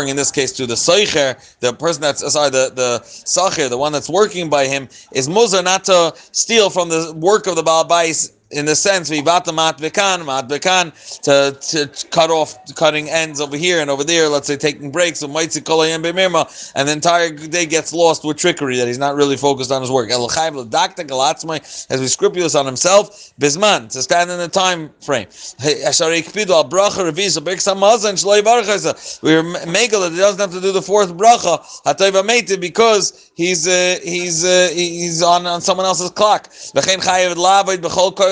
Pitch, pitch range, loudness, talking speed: 170 Hz, 145-185 Hz, -15 LUFS, 160 wpm